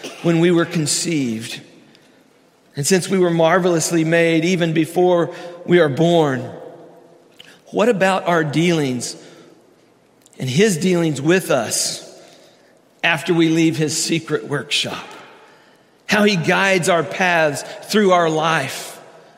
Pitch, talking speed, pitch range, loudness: 165 Hz, 120 wpm, 160-175 Hz, -17 LUFS